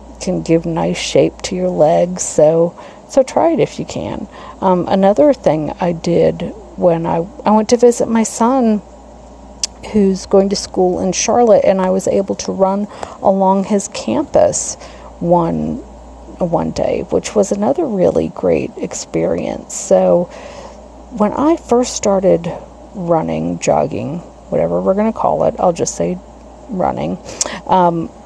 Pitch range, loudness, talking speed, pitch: 175-230 Hz, -15 LUFS, 145 wpm, 195 Hz